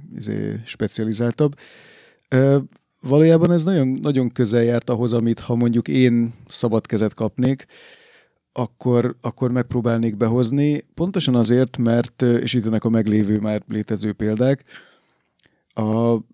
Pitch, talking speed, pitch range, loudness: 120 Hz, 110 wpm, 115-135 Hz, -20 LUFS